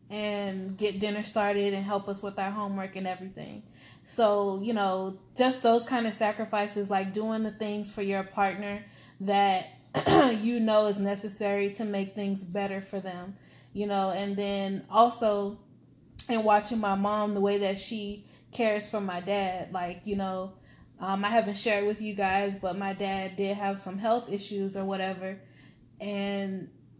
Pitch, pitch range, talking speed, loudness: 200 Hz, 195-210 Hz, 170 wpm, -29 LUFS